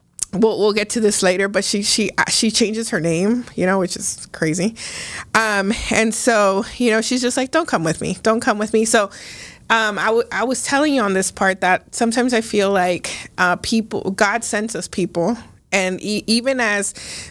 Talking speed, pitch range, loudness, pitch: 210 wpm, 190-230 Hz, -18 LUFS, 215 Hz